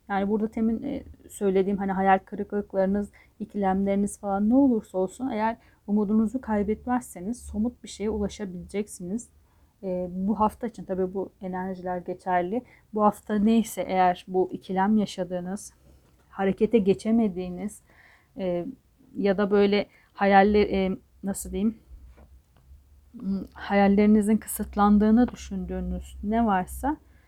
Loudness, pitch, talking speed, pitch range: -26 LUFS, 200 Hz, 105 wpm, 185-215 Hz